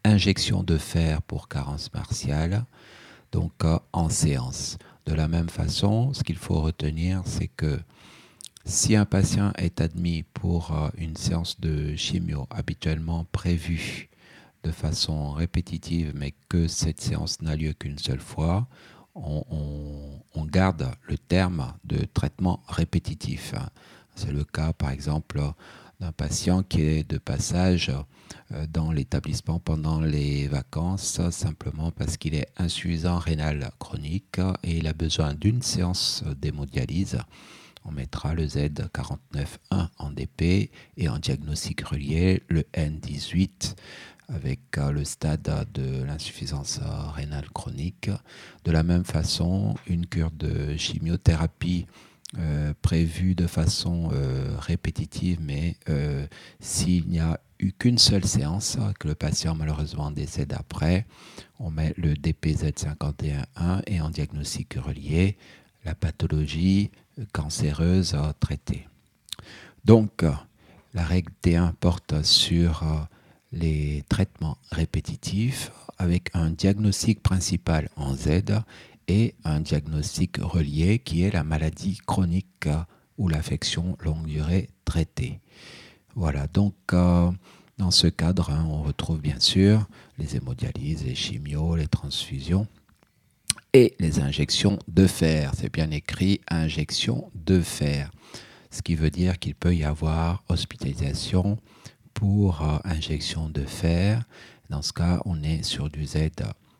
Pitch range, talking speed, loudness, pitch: 75-95 Hz, 120 wpm, -26 LUFS, 85 Hz